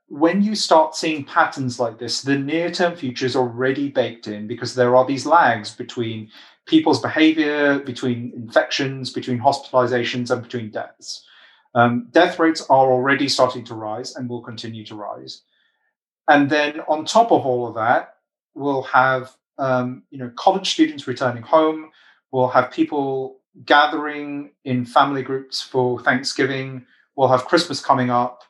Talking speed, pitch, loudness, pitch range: 155 wpm, 130 Hz, -19 LUFS, 125-150 Hz